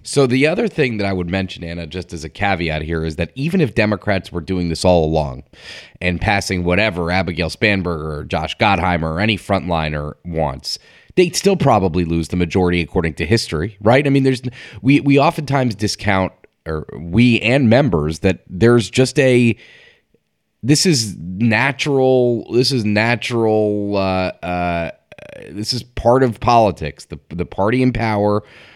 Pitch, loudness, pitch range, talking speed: 100 Hz, -17 LUFS, 85-120 Hz, 165 wpm